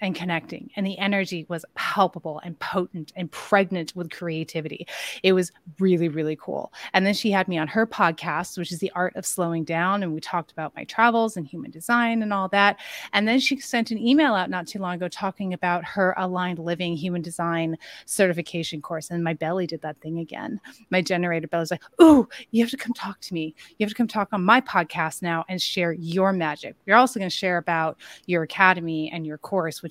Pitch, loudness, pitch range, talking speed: 180 Hz, -24 LUFS, 165-200 Hz, 220 wpm